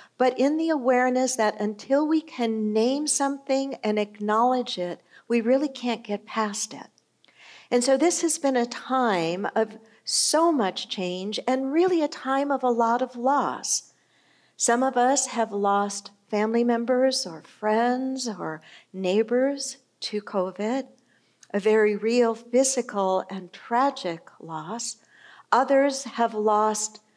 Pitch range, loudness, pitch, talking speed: 210-265 Hz, -24 LUFS, 235 Hz, 135 wpm